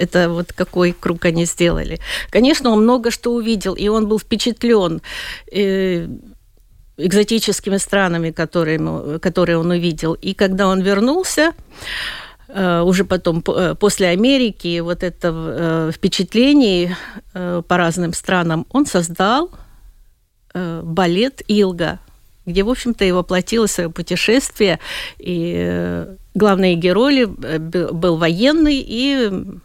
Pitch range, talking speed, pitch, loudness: 170-215 Hz, 105 wpm, 185 Hz, -17 LUFS